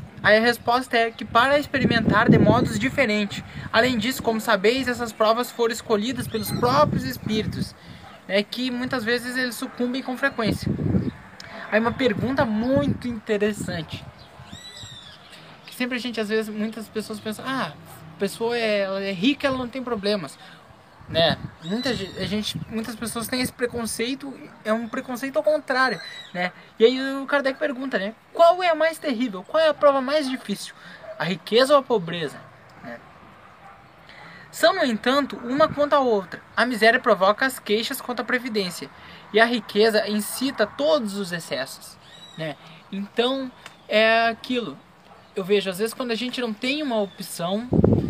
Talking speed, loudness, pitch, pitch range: 160 wpm, -23 LUFS, 230 Hz, 210-260 Hz